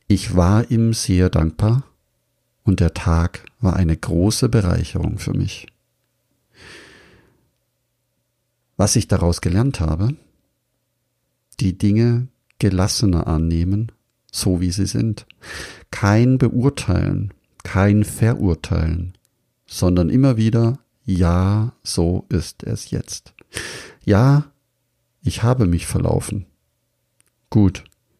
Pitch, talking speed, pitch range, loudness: 105 Hz, 95 wpm, 90-120 Hz, -19 LUFS